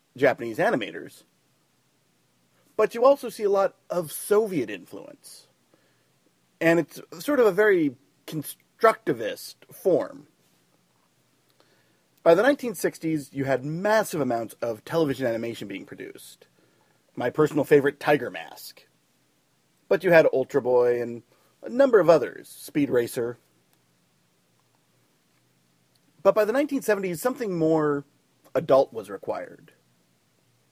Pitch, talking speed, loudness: 155 Hz, 110 wpm, -24 LUFS